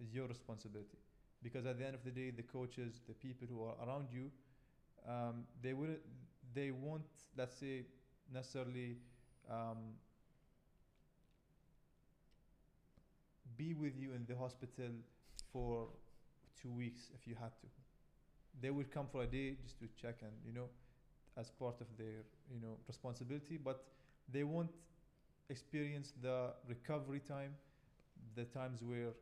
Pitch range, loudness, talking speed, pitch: 120-140 Hz, -49 LUFS, 140 wpm, 130 Hz